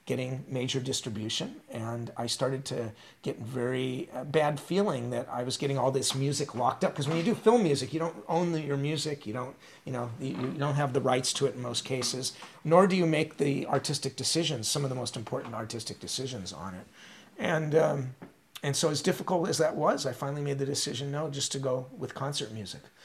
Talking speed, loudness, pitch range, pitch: 220 wpm, -30 LUFS, 125-155 Hz, 140 Hz